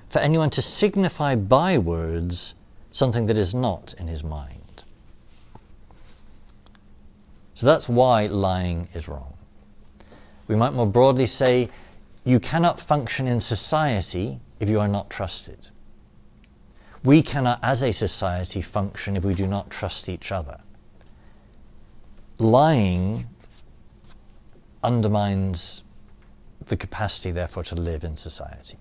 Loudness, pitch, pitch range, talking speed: -22 LUFS, 105 Hz, 90-125 Hz, 115 wpm